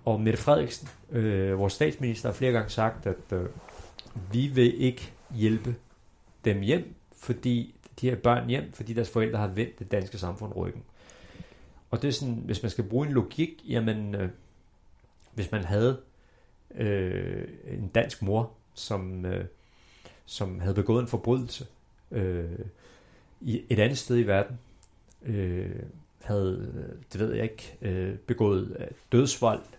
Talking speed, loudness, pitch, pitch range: 150 wpm, -29 LUFS, 115 Hz, 100-125 Hz